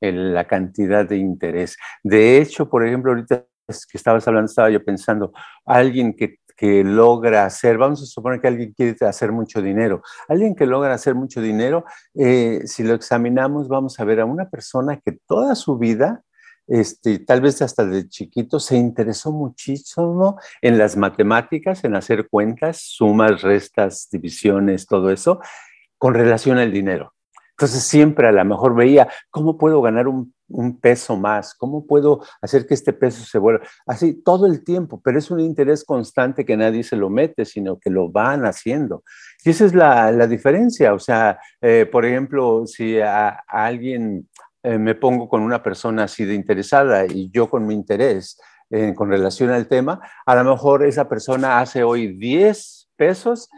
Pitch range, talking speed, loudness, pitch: 105-140 Hz, 175 wpm, -17 LUFS, 120 Hz